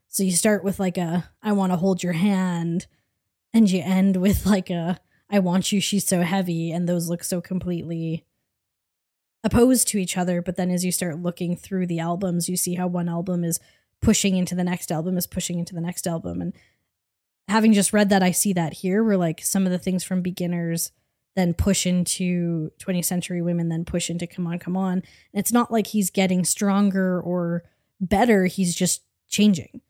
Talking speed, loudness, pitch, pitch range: 205 wpm, -23 LUFS, 180 Hz, 175-195 Hz